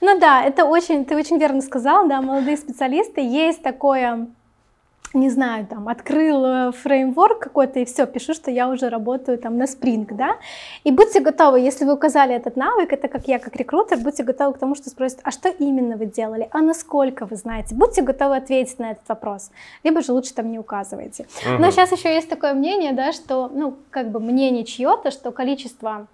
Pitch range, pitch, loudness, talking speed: 245-305 Hz, 270 Hz, -19 LUFS, 195 wpm